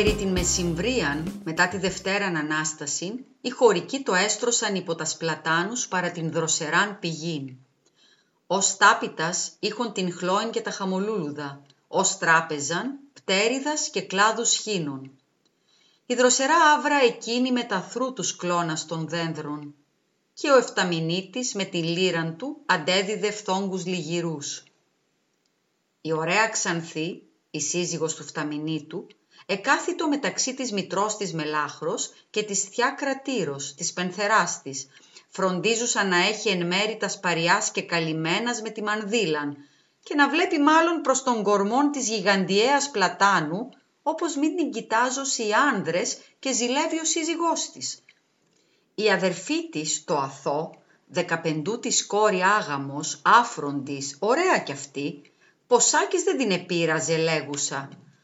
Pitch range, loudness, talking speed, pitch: 160-240 Hz, -24 LUFS, 125 wpm, 190 Hz